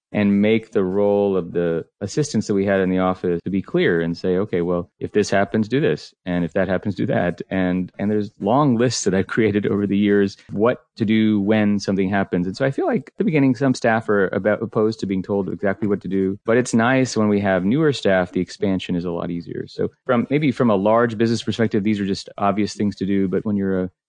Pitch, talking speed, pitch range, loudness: 100 Hz, 250 wpm, 95-110 Hz, -20 LUFS